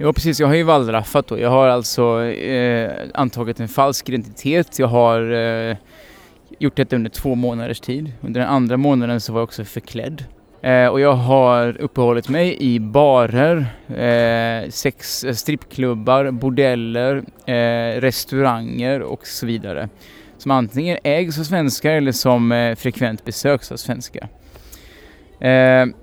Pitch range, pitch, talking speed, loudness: 115-135 Hz, 125 Hz, 150 wpm, -18 LUFS